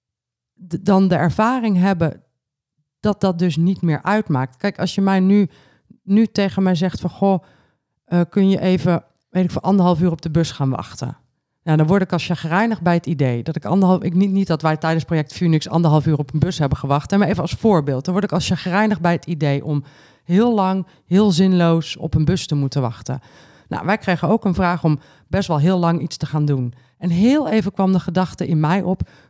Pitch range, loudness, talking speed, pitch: 155-190 Hz, -18 LUFS, 225 wpm, 175 Hz